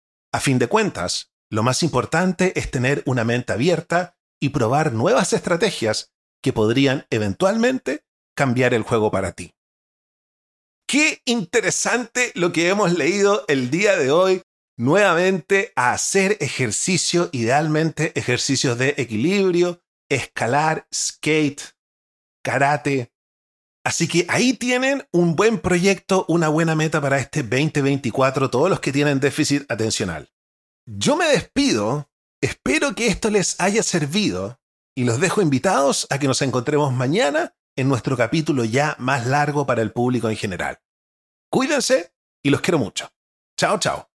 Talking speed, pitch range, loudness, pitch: 135 wpm, 125-185 Hz, -20 LUFS, 145 Hz